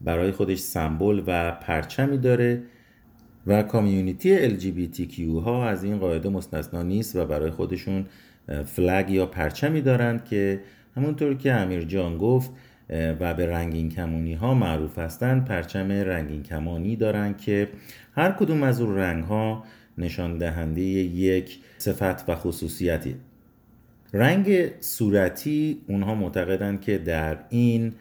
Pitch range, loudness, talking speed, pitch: 85-115 Hz, -25 LUFS, 135 wpm, 100 Hz